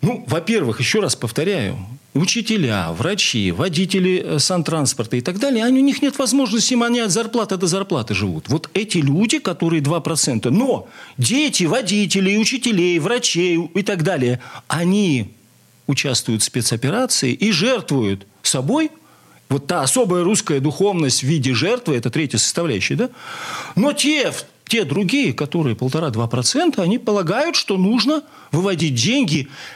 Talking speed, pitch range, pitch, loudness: 135 wpm, 135-220 Hz, 175 Hz, -18 LUFS